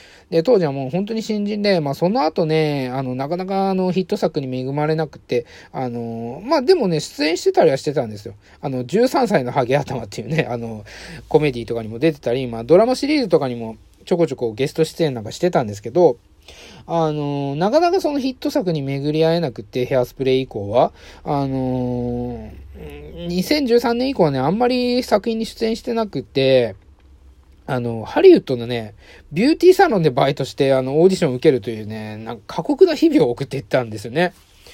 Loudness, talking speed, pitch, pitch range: -19 LUFS, 390 characters per minute, 145 Hz, 120-195 Hz